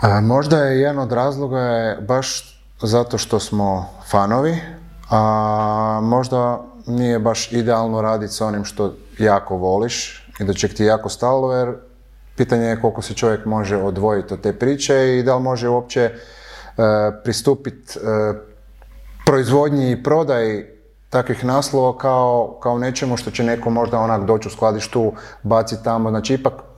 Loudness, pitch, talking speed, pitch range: -18 LUFS, 115 Hz, 150 wpm, 110-125 Hz